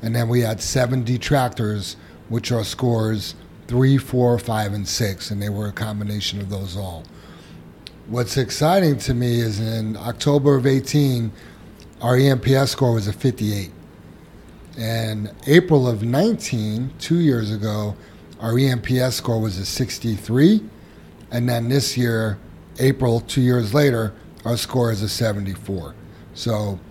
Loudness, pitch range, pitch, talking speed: -20 LUFS, 105-130 Hz, 115 Hz, 145 wpm